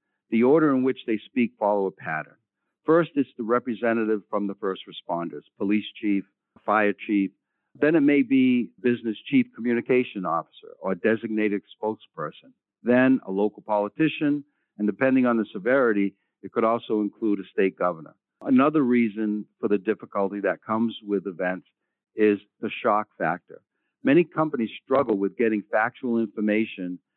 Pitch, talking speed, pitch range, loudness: 110 Hz, 150 wpm, 100-125 Hz, -25 LUFS